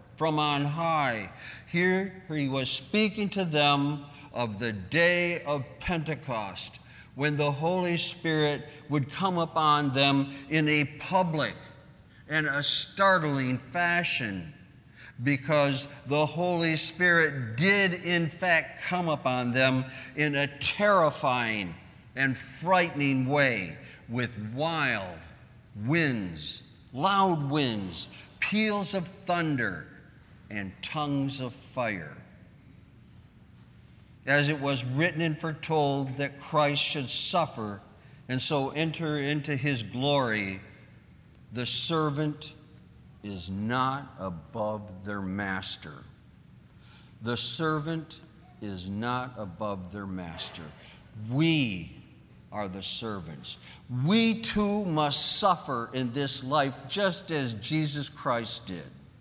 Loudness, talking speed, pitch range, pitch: -28 LUFS, 105 wpm, 115-155 Hz, 140 Hz